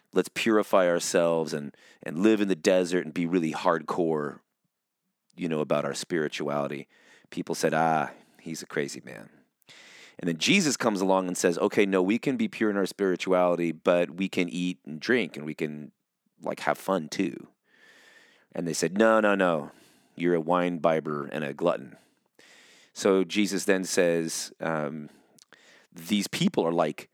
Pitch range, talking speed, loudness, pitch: 80-95 Hz, 170 wpm, -27 LUFS, 90 Hz